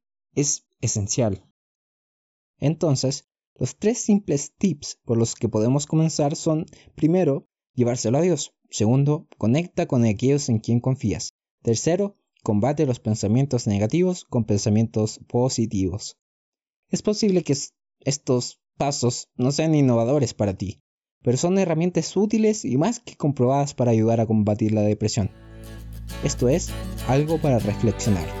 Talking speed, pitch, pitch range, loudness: 130 wpm, 125 Hz, 110-160 Hz, -23 LUFS